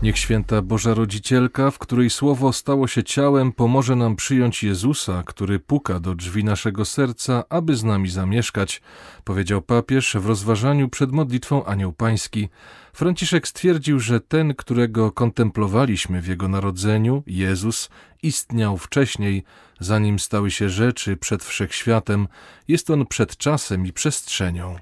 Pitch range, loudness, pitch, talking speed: 100-135 Hz, -21 LUFS, 115 Hz, 135 wpm